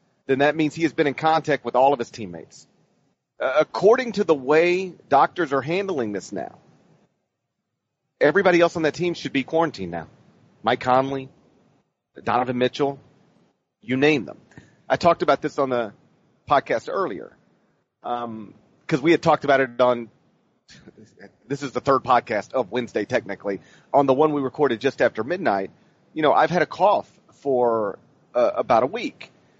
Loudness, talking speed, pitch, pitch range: -22 LUFS, 165 wpm, 140 Hz, 125-160 Hz